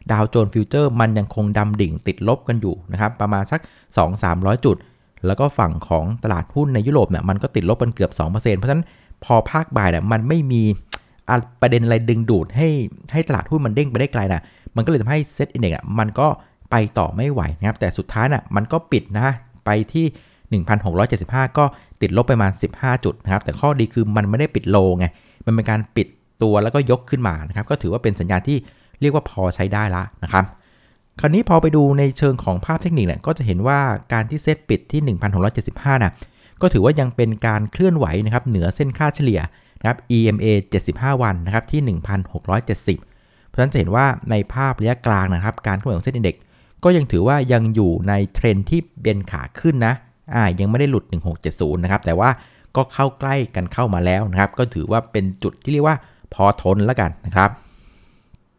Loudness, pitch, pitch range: -19 LUFS, 110 Hz, 95-135 Hz